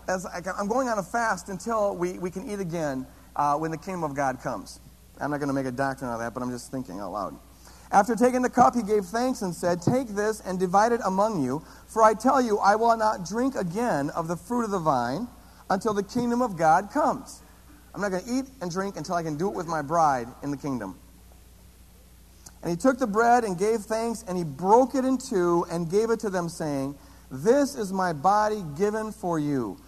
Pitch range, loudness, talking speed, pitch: 160-225 Hz, -26 LUFS, 235 wpm, 190 Hz